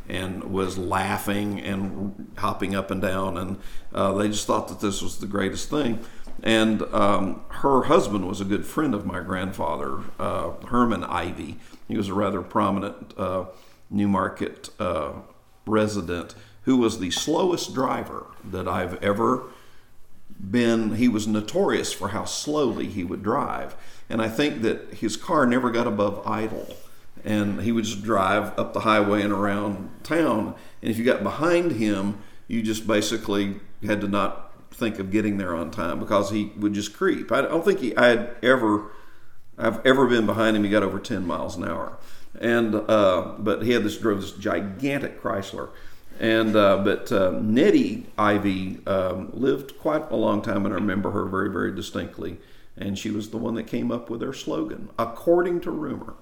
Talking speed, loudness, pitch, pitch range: 175 wpm, -24 LUFS, 105 Hz, 100-110 Hz